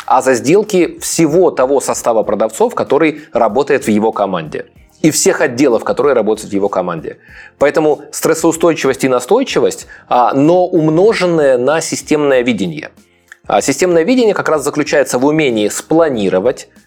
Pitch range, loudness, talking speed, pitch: 110-185 Hz, -13 LUFS, 135 wpm, 165 Hz